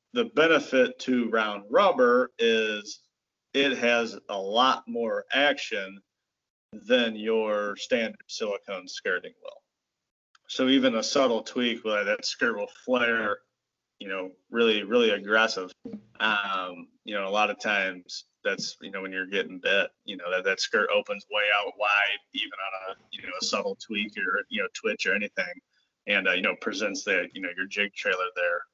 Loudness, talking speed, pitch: -26 LUFS, 170 wpm, 130 Hz